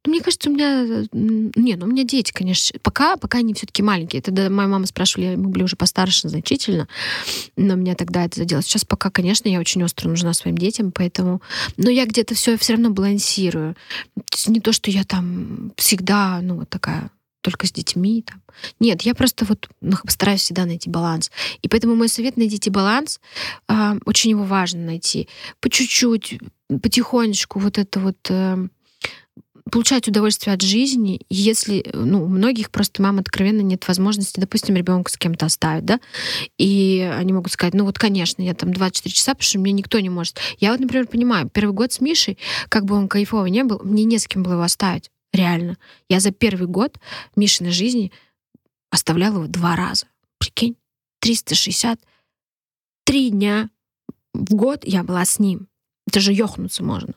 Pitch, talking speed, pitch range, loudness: 200 Hz, 170 wpm, 185-225 Hz, -19 LUFS